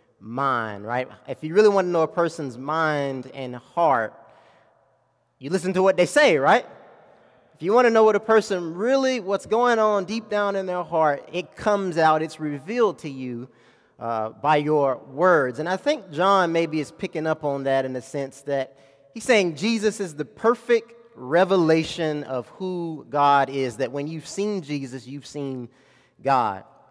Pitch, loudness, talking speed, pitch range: 160 Hz, -23 LUFS, 180 wpm, 140-195 Hz